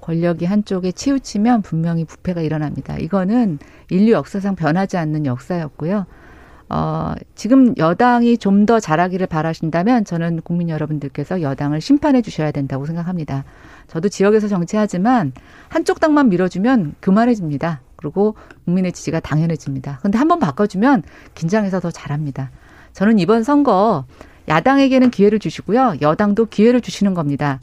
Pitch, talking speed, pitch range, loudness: 185 Hz, 370 characters per minute, 155-220 Hz, -17 LUFS